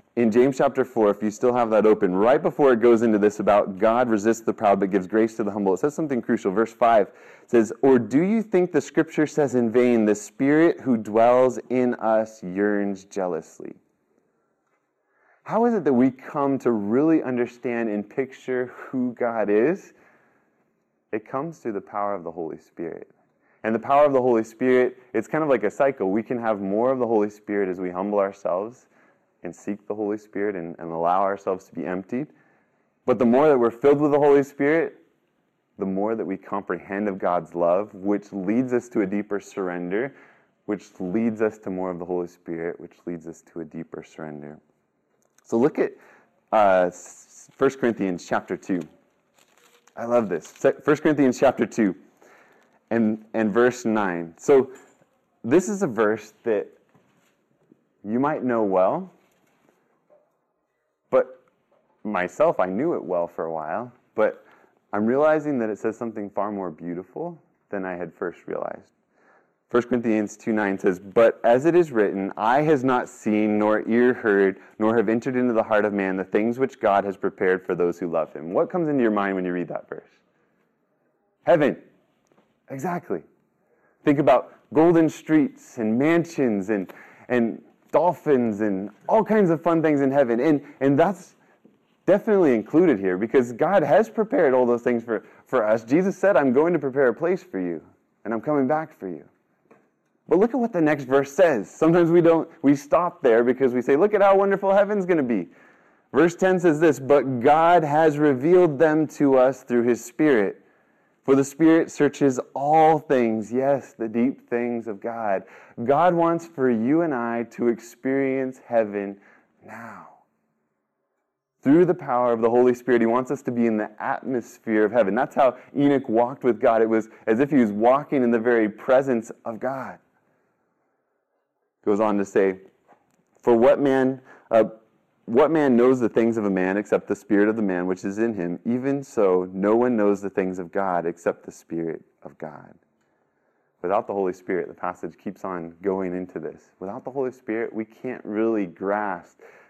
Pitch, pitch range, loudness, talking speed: 115 Hz, 105-140 Hz, -22 LUFS, 185 wpm